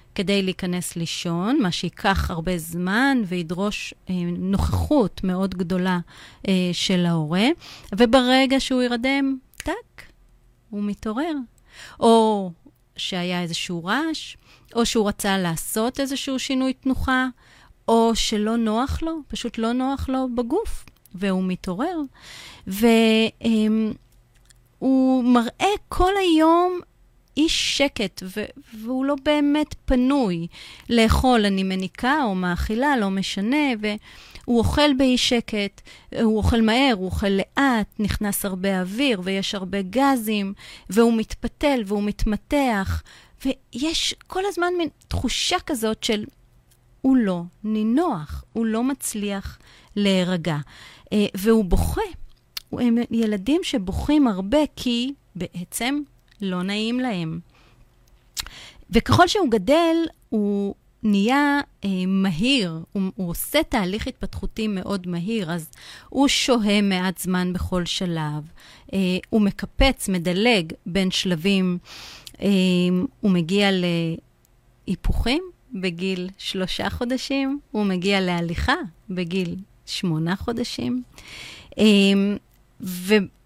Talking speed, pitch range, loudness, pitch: 105 wpm, 185-260 Hz, -22 LUFS, 215 Hz